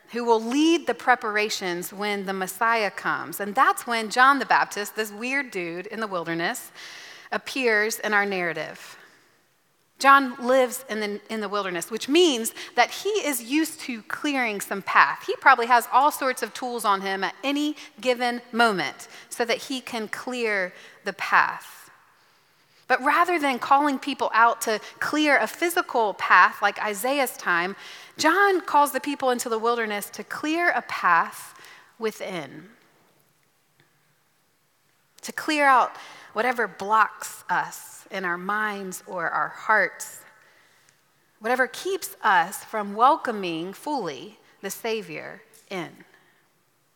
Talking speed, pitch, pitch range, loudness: 140 wpm, 230 Hz, 205-275 Hz, -23 LUFS